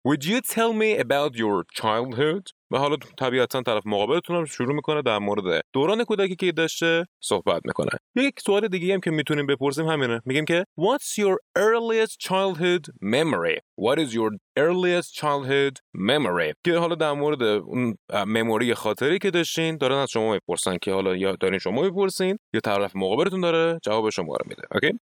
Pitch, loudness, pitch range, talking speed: 165 Hz, -24 LUFS, 125-195 Hz, 170 wpm